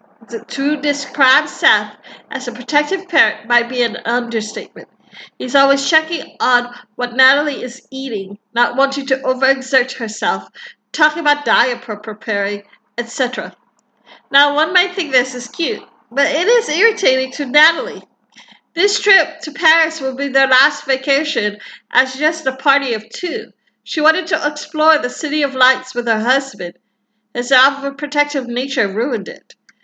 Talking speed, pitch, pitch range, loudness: 150 wpm, 265 Hz, 240-295 Hz, -15 LUFS